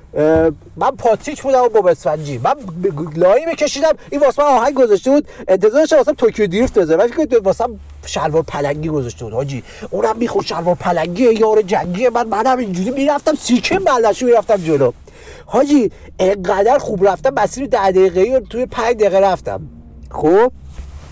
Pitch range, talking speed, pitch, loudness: 175-265 Hz, 160 wpm, 215 Hz, -15 LUFS